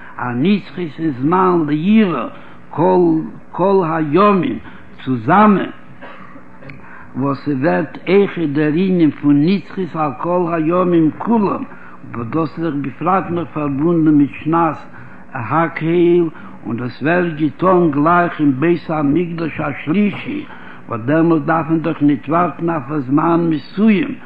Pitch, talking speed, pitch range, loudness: 160 Hz, 115 wpm, 145-175 Hz, -16 LUFS